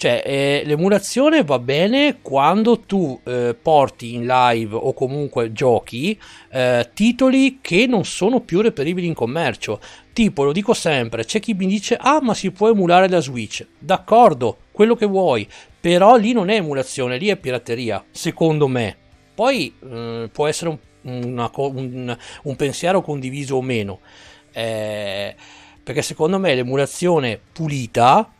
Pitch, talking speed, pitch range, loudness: 150 Hz, 150 wpm, 125-200 Hz, -18 LUFS